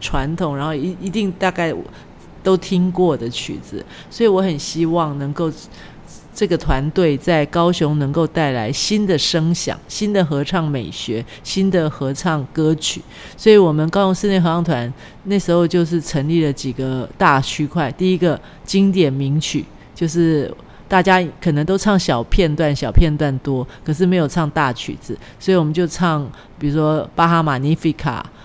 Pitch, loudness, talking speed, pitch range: 160 Hz, -18 LUFS, 250 characters per minute, 145-180 Hz